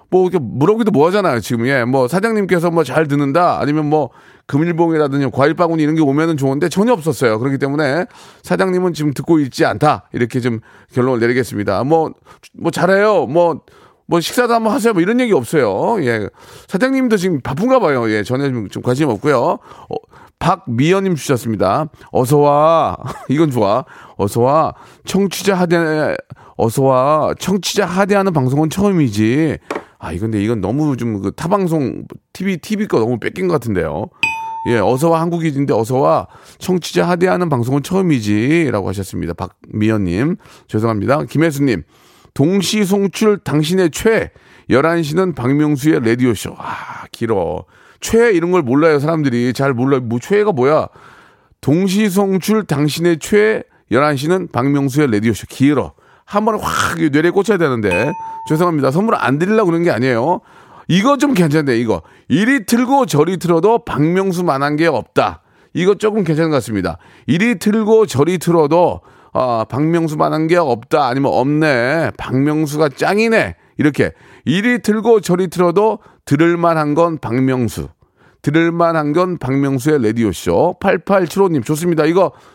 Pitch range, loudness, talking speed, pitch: 135-190 Hz, -15 LUFS, 325 characters per minute, 160 Hz